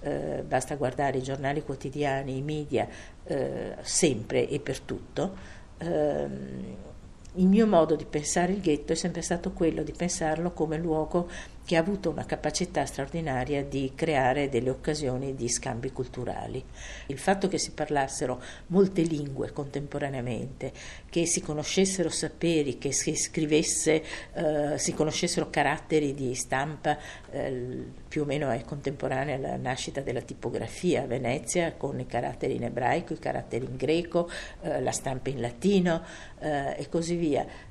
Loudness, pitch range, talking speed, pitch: -29 LUFS, 135-165 Hz, 150 wpm, 150 Hz